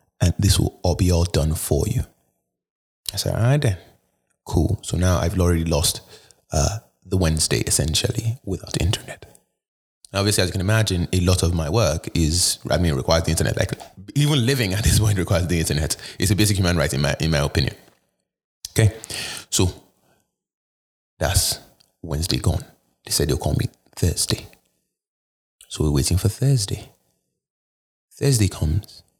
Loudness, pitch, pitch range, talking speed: -21 LUFS, 90 Hz, 80-110 Hz, 165 wpm